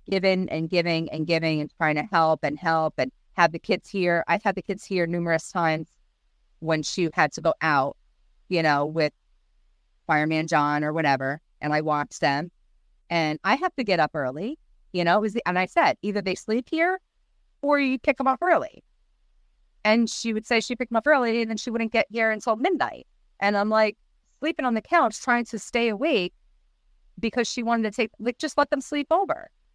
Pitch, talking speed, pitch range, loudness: 190 Hz, 205 wpm, 155-235 Hz, -24 LUFS